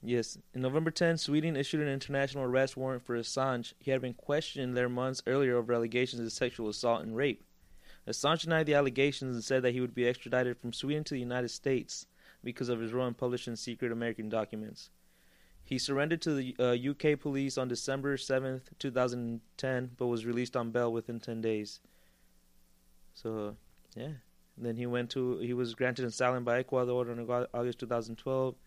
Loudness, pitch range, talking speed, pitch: -33 LUFS, 115-130 Hz, 185 wpm, 125 Hz